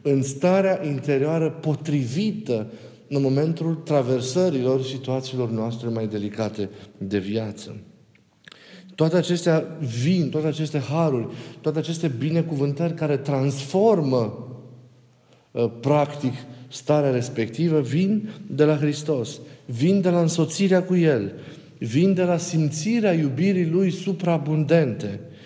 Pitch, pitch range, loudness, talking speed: 150 Hz, 125-165 Hz, -23 LUFS, 105 wpm